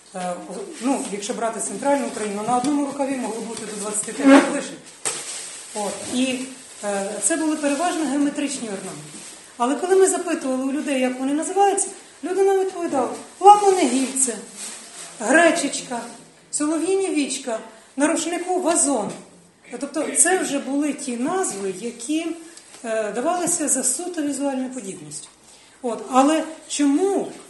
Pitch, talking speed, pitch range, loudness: 275 Hz, 110 wpm, 235-320 Hz, -21 LUFS